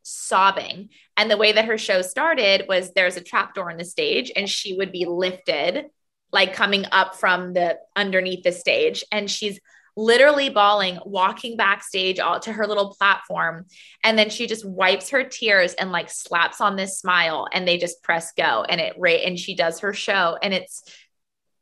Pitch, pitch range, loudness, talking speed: 195 Hz, 185-215 Hz, -20 LUFS, 190 wpm